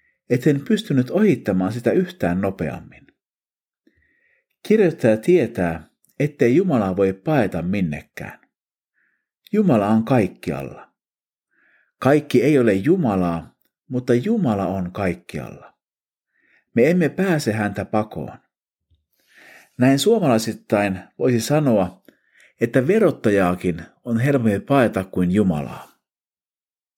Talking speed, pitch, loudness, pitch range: 90 wpm, 110 Hz, -20 LUFS, 95-140 Hz